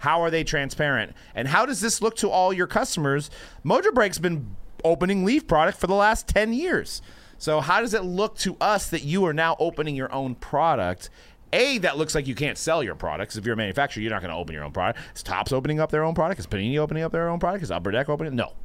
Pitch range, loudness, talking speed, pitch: 130-185 Hz, -24 LUFS, 255 wpm, 155 Hz